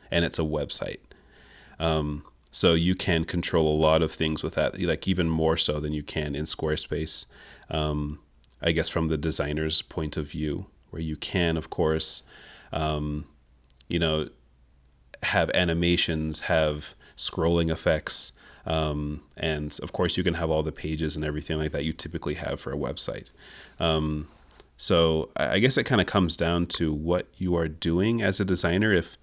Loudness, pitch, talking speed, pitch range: -25 LUFS, 80 Hz, 170 wpm, 75-85 Hz